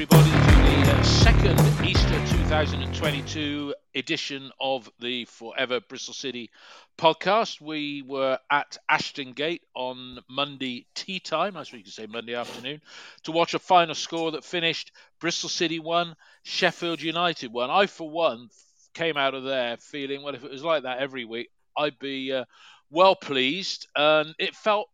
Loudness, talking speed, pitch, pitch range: -25 LUFS, 160 wpm, 145 Hz, 130-165 Hz